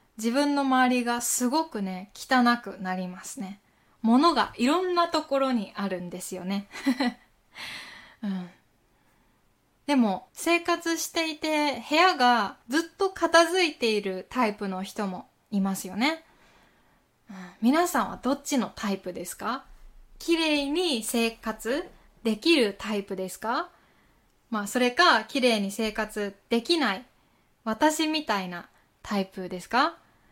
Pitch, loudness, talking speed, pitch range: 240 Hz, -26 LUFS, 240 characters per minute, 200-300 Hz